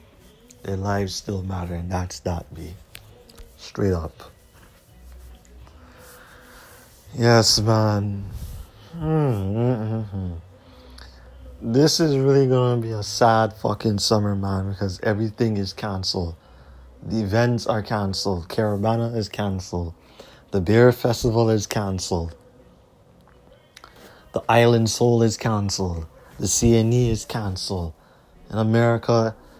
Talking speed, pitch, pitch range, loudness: 100 wpm, 100 Hz, 85-115 Hz, -22 LUFS